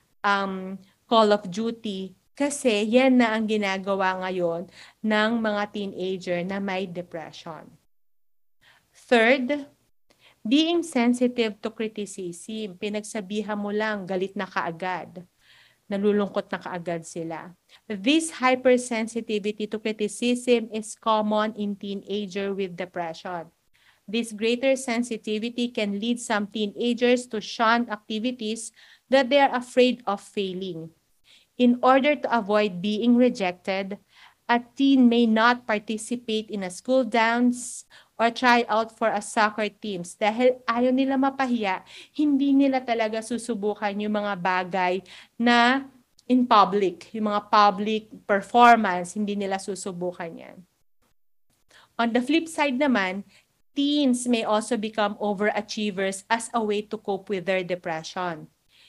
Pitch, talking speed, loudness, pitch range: 215 Hz, 120 wpm, -24 LUFS, 195-240 Hz